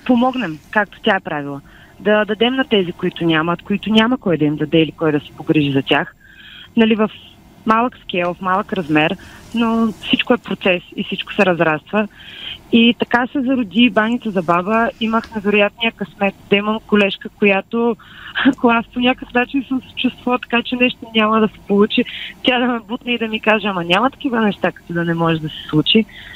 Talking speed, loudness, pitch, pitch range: 200 wpm, -17 LUFS, 215 Hz, 180-235 Hz